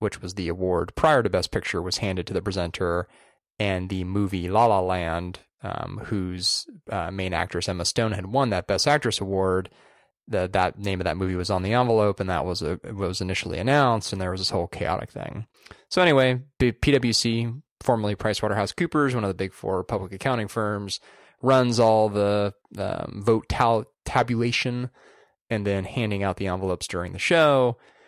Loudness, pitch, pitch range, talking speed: -24 LUFS, 100 Hz, 95-115 Hz, 185 wpm